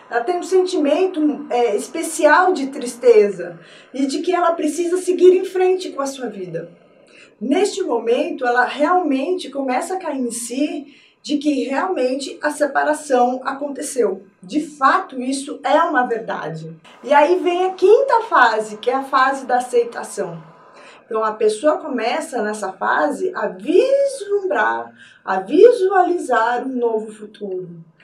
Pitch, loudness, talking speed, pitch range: 270 Hz, -18 LUFS, 140 wpm, 230-335 Hz